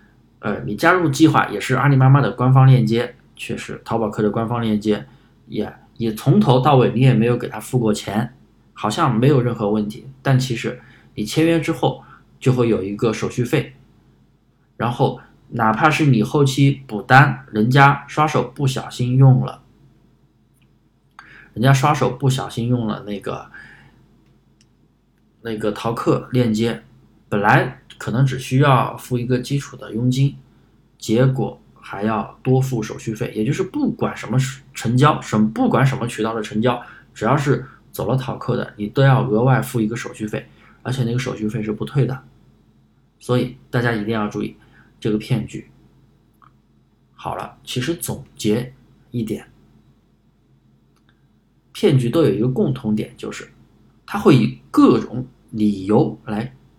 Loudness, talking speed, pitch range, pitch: -19 LUFS, 230 characters per minute, 110-130 Hz, 120 Hz